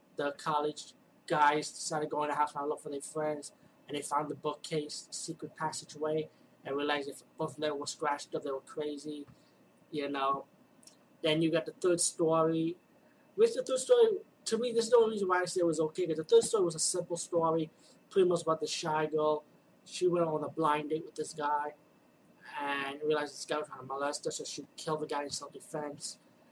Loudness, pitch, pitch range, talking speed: -33 LUFS, 155 Hz, 145-170 Hz, 215 wpm